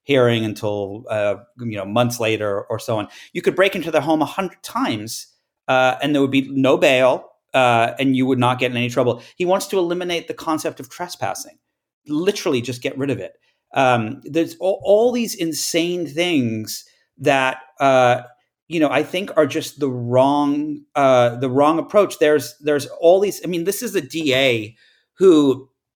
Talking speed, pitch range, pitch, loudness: 185 wpm, 125-165 Hz, 140 Hz, -19 LUFS